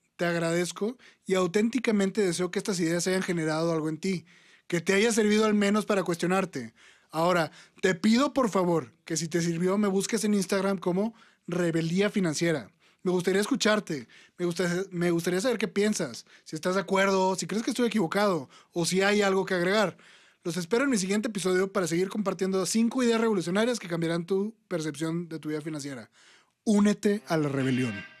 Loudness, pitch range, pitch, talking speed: -27 LUFS, 170-205 Hz, 190 Hz, 185 wpm